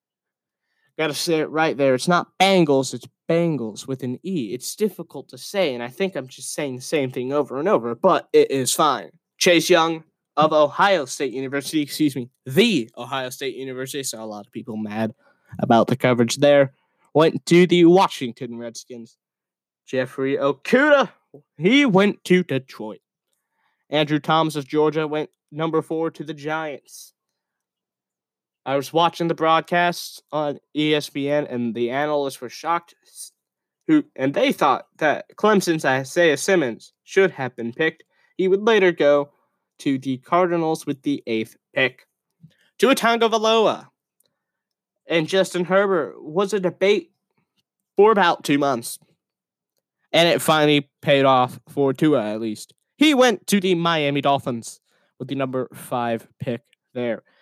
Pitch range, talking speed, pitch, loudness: 130-175 Hz, 150 wpm, 150 Hz, -20 LUFS